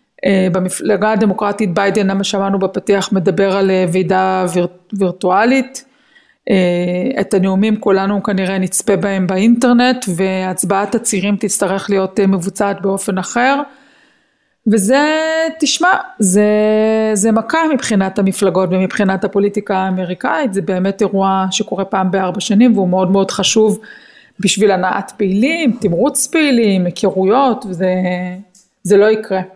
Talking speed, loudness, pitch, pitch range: 120 wpm, -14 LUFS, 200 Hz, 190-225 Hz